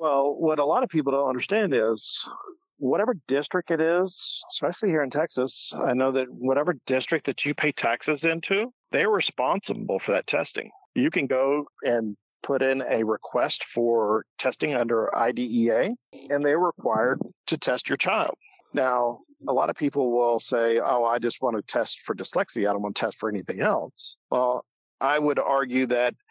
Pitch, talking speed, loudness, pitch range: 140 Hz, 180 wpm, -25 LUFS, 120-160 Hz